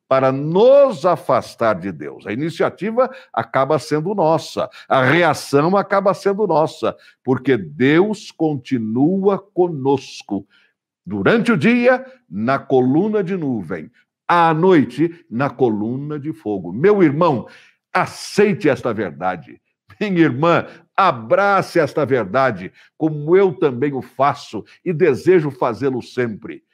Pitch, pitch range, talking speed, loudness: 165 Hz, 135-195 Hz, 115 wpm, -17 LUFS